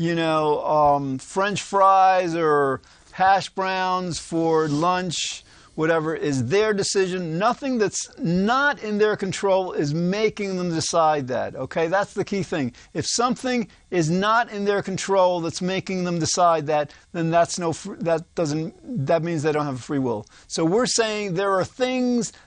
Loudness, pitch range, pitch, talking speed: -22 LUFS, 160-195 Hz, 180 Hz, 165 wpm